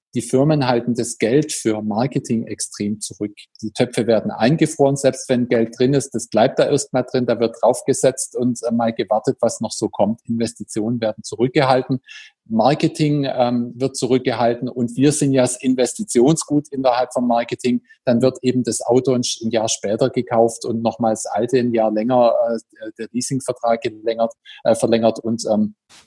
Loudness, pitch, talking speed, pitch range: -19 LUFS, 120 Hz, 175 wpm, 115-130 Hz